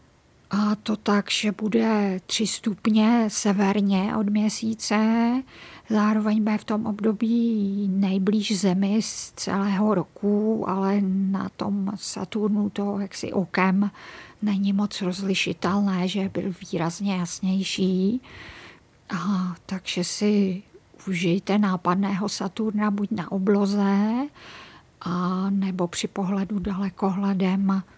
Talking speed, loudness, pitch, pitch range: 105 wpm, -24 LUFS, 200 Hz, 190-210 Hz